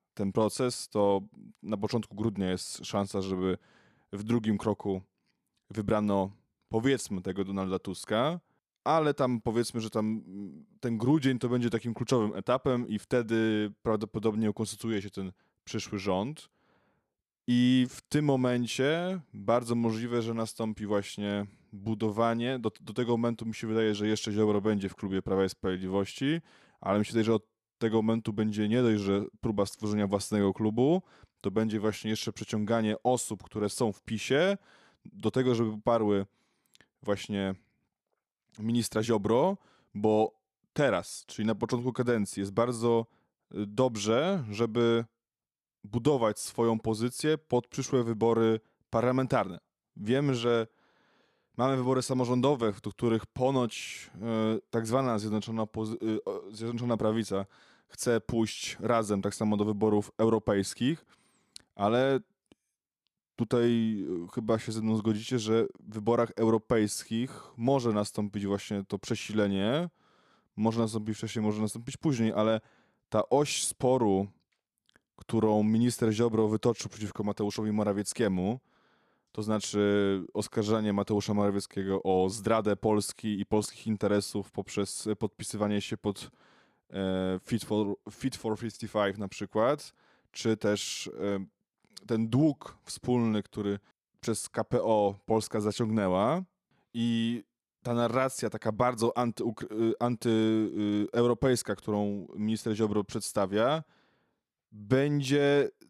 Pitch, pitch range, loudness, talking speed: 110 Hz, 105-120 Hz, -30 LUFS, 120 wpm